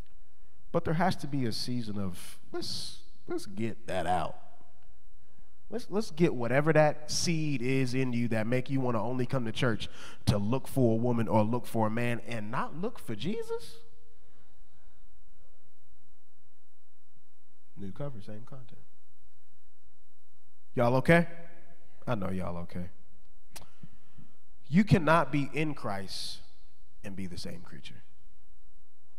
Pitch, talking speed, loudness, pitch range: 120 Hz, 135 wpm, -31 LUFS, 105-150 Hz